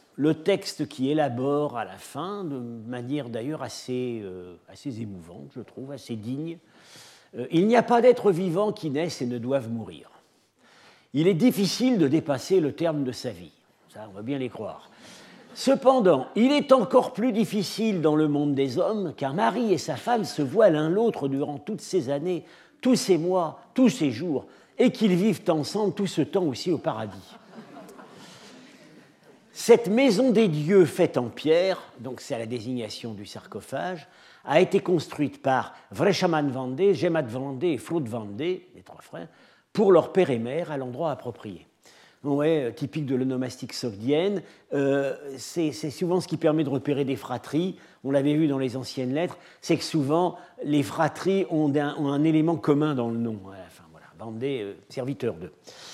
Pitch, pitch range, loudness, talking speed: 150 Hz, 130-185 Hz, -25 LUFS, 180 wpm